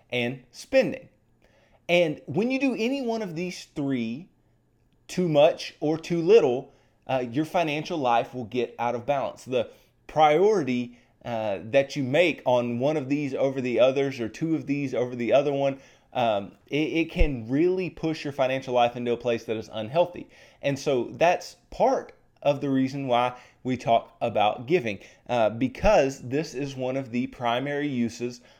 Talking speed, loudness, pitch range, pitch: 170 wpm, -26 LUFS, 120-155 Hz, 135 Hz